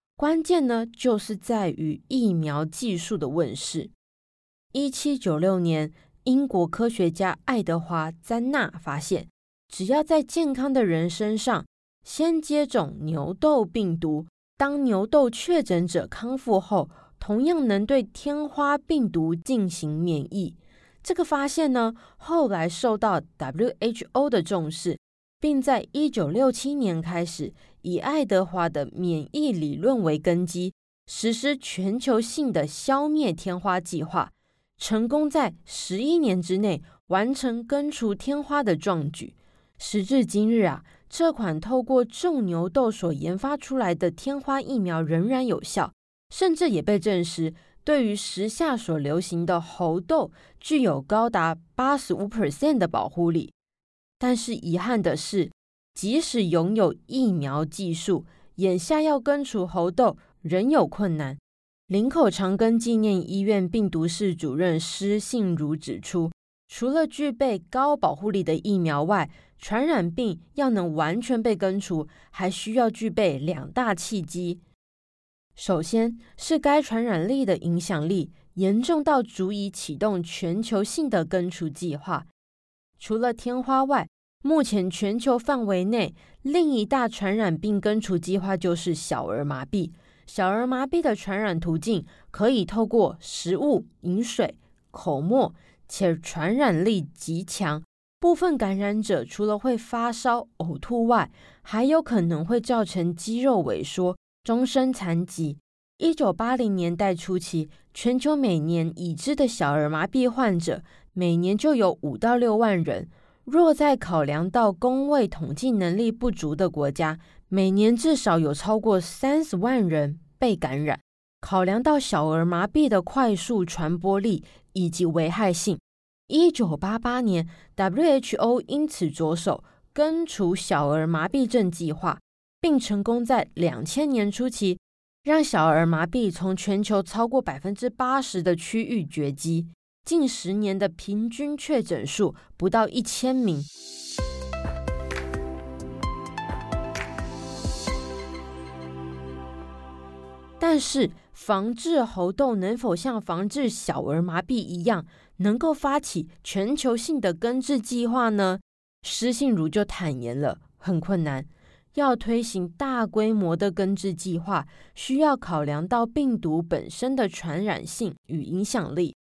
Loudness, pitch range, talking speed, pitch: -25 LUFS, 170-250 Hz, 205 characters per minute, 200 Hz